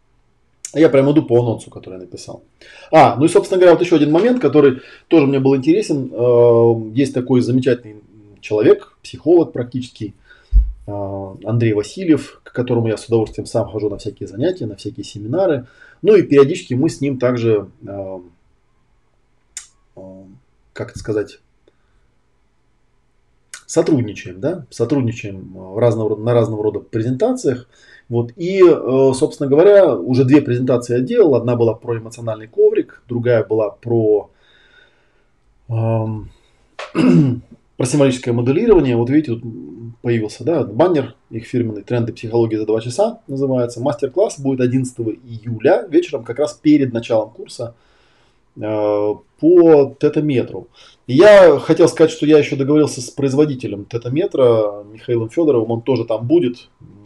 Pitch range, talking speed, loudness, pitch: 110-145 Hz, 130 wpm, -15 LUFS, 120 Hz